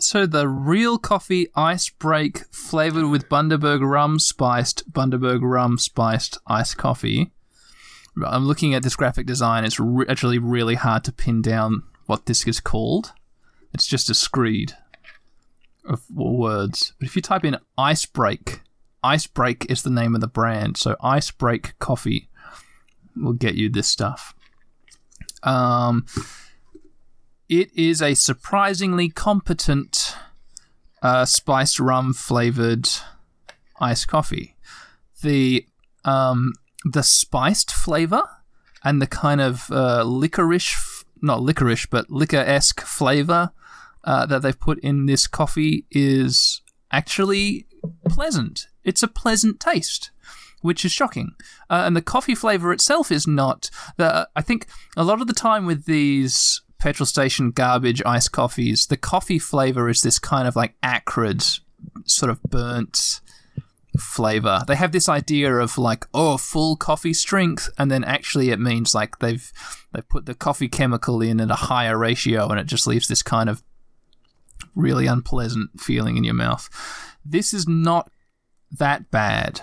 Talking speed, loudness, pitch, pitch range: 145 wpm, -20 LUFS, 135 Hz, 120-165 Hz